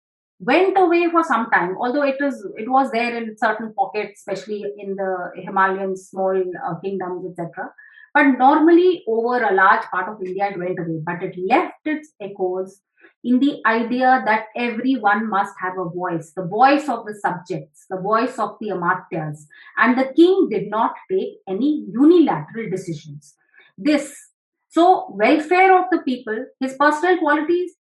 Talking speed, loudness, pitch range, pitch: 160 wpm, -19 LUFS, 190-285 Hz, 220 Hz